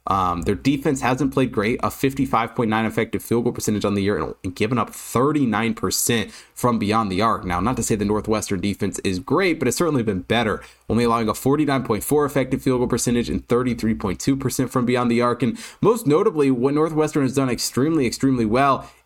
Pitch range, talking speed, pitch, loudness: 110-135 Hz, 190 wpm, 120 Hz, -21 LUFS